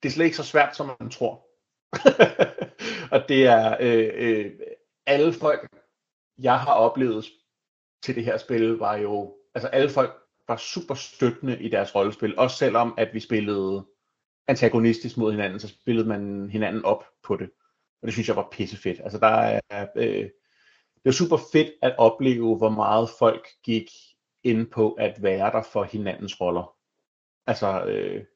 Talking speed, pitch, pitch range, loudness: 170 wpm, 115 Hz, 110-140 Hz, -23 LUFS